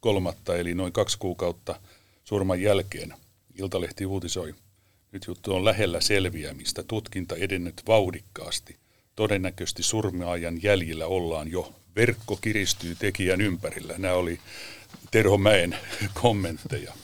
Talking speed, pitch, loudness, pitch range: 110 wpm, 95 Hz, -27 LUFS, 90-105 Hz